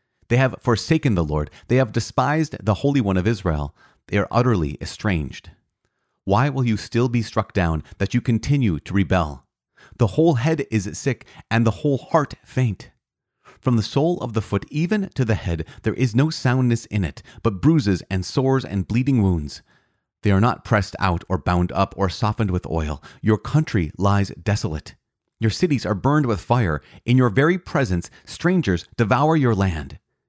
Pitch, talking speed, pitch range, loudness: 110 Hz, 180 wpm, 95-130 Hz, -21 LUFS